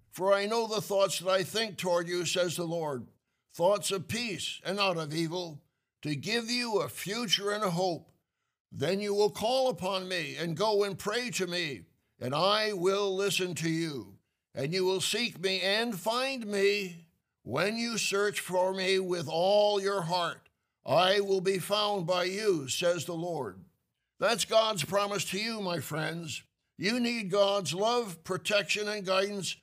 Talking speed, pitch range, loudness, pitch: 175 wpm, 175-205 Hz, -30 LUFS, 190 Hz